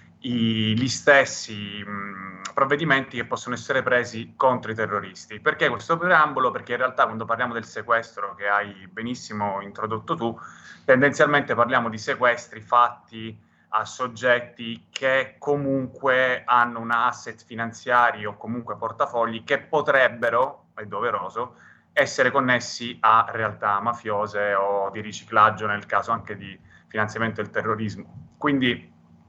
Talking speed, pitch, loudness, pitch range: 125 wpm, 115 Hz, -23 LUFS, 105-125 Hz